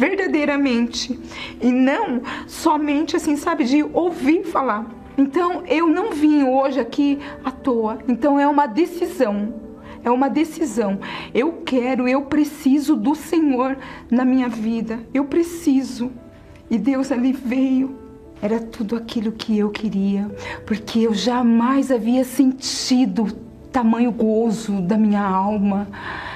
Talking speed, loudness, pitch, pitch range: 125 wpm, -20 LUFS, 260 Hz, 230-290 Hz